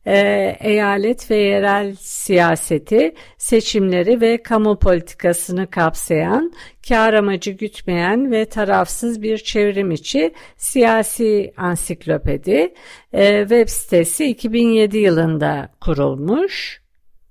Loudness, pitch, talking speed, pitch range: -17 LUFS, 205 Hz, 85 wpm, 180-225 Hz